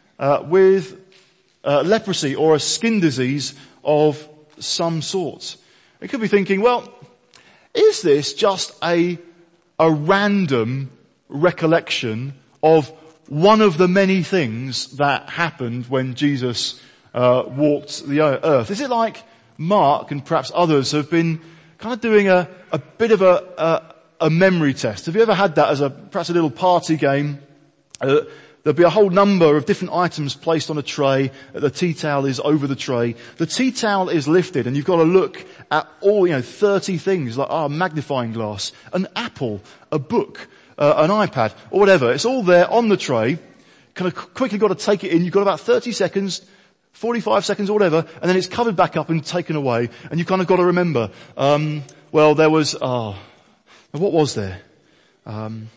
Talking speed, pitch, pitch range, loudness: 180 wpm, 165 Hz, 145-190 Hz, -18 LUFS